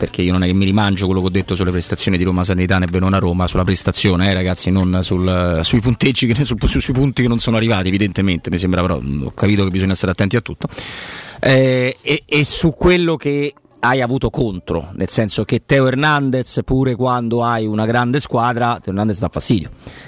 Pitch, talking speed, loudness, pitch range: 105 Hz, 205 wpm, -16 LUFS, 95-125 Hz